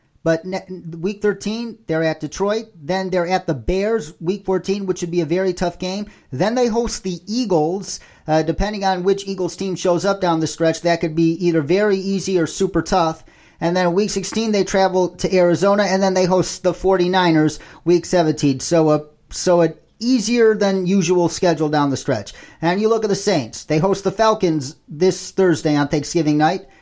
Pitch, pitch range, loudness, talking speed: 185 Hz, 165-195 Hz, -19 LUFS, 195 wpm